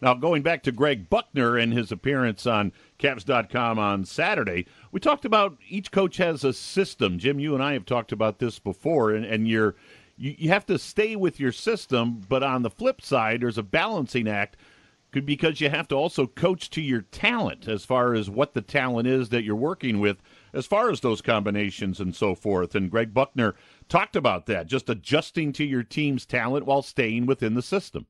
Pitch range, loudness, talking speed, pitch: 110-145 Hz, -25 LUFS, 205 wpm, 125 Hz